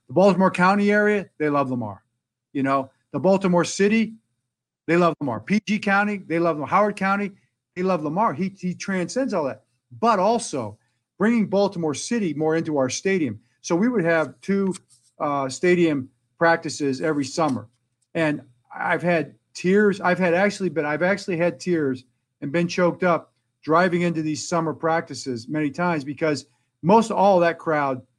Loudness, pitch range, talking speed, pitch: -22 LUFS, 135-185 Hz, 165 wpm, 165 Hz